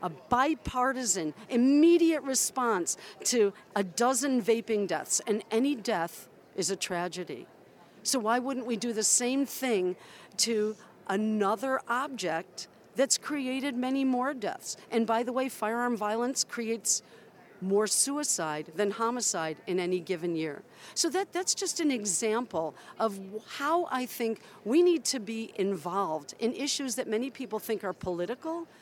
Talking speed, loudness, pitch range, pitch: 145 wpm, -29 LUFS, 200-260 Hz, 230 Hz